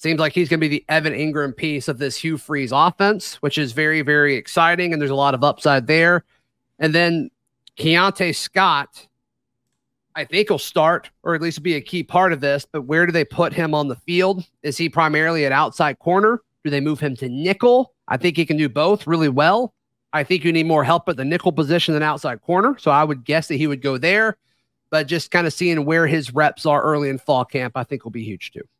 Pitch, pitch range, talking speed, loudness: 155 Hz, 145-170 Hz, 240 wpm, -19 LUFS